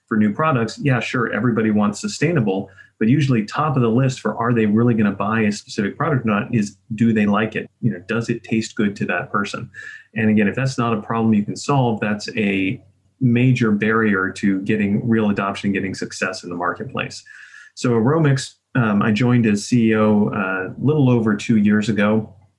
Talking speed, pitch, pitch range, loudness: 205 wpm, 110 Hz, 105-120 Hz, -19 LUFS